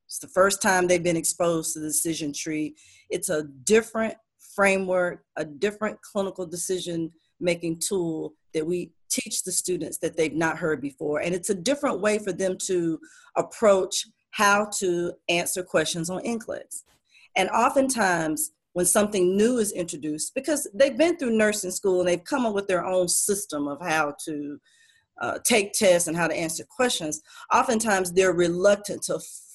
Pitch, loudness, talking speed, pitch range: 180 Hz, -25 LUFS, 165 wpm, 160-210 Hz